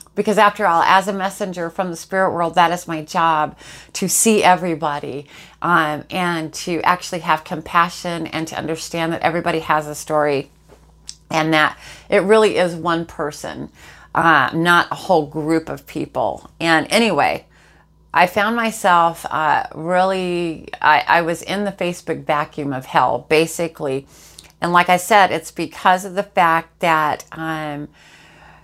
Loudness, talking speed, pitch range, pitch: -18 LUFS, 155 wpm, 155-180 Hz, 165 Hz